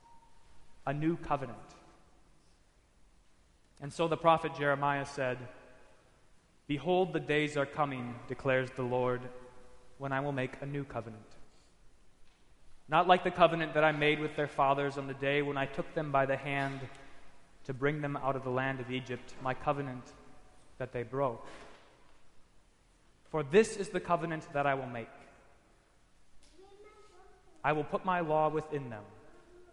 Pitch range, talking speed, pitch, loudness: 130-155 Hz, 150 wpm, 140 Hz, -33 LUFS